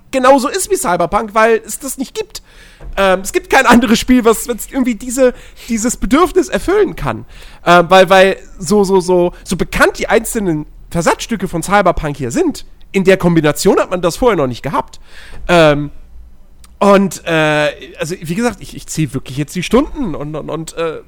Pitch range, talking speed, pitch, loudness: 155-240 Hz, 180 wpm, 190 Hz, -13 LUFS